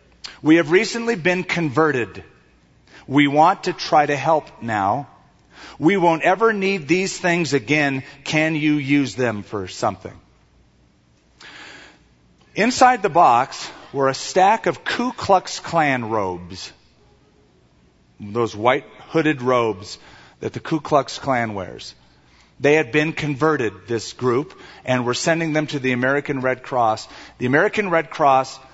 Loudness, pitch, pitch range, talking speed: -19 LUFS, 140 Hz, 115-165 Hz, 135 wpm